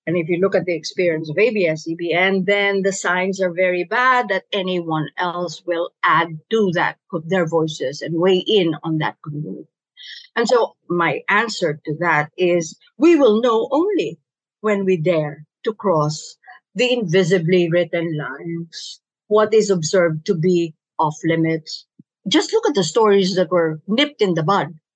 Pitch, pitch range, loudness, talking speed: 180 Hz, 165-200 Hz, -19 LUFS, 170 wpm